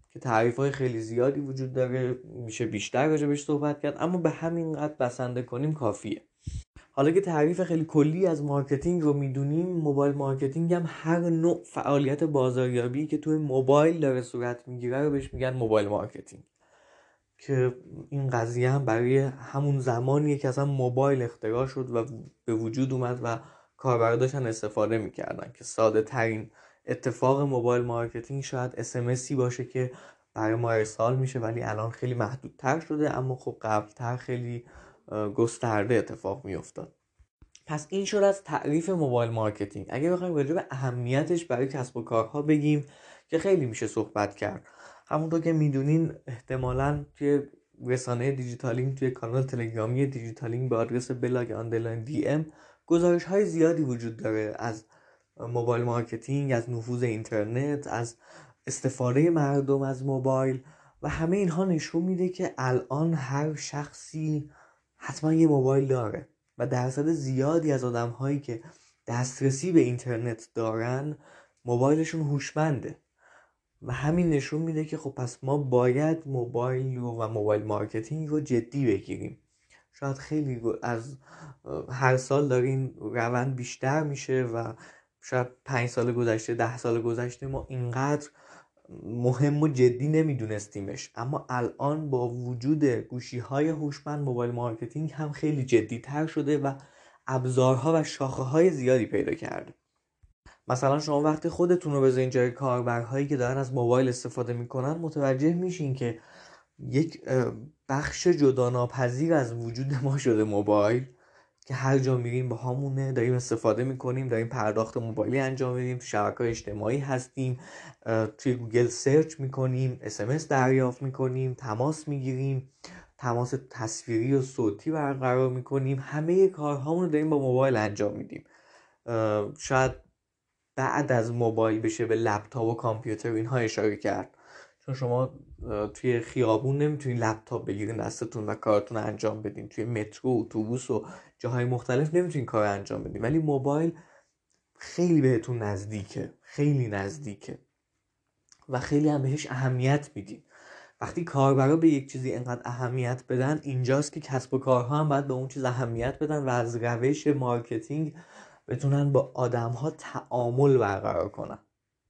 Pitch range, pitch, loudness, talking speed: 120-145 Hz, 130 Hz, -28 LUFS, 140 wpm